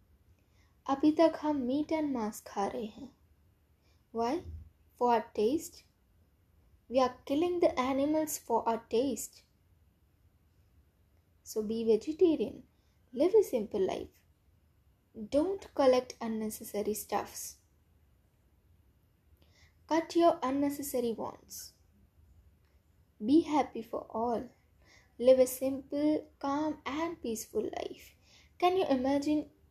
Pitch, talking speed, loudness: 230 Hz, 100 wpm, -32 LUFS